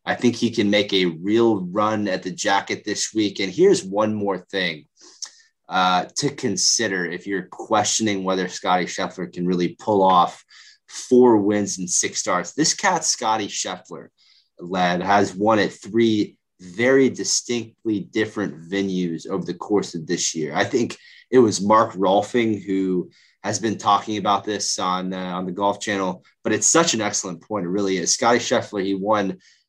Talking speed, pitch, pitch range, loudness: 175 wpm, 100 Hz, 95-110 Hz, -21 LUFS